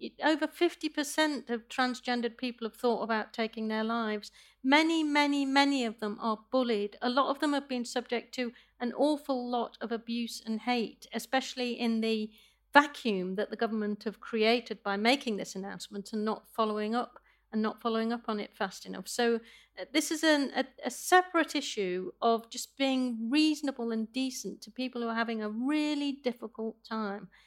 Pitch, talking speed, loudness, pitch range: 235 Hz, 180 wpm, -31 LUFS, 220-270 Hz